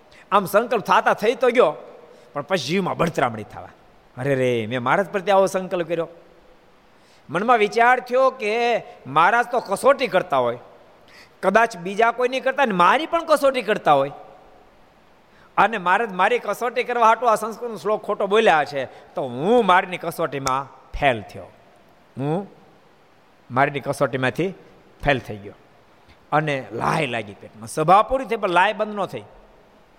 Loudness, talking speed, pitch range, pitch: -20 LUFS, 150 wpm, 145-235 Hz, 195 Hz